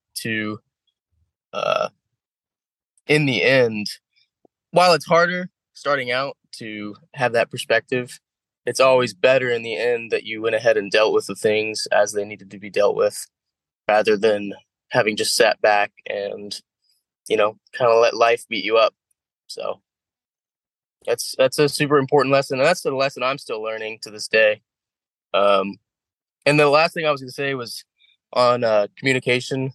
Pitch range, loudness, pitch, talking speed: 110-145 Hz, -20 LUFS, 125 Hz, 165 wpm